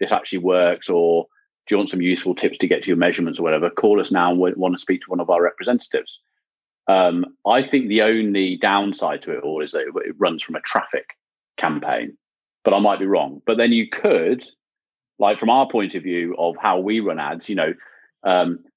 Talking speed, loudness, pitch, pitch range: 225 wpm, -20 LUFS, 100 Hz, 90-125 Hz